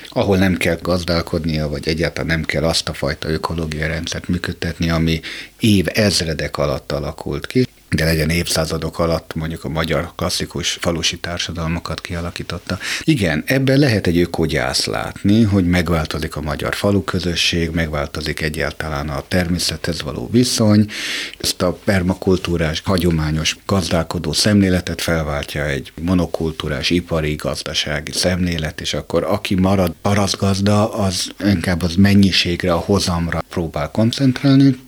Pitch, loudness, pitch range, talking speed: 85 Hz, -18 LUFS, 80-95 Hz, 125 wpm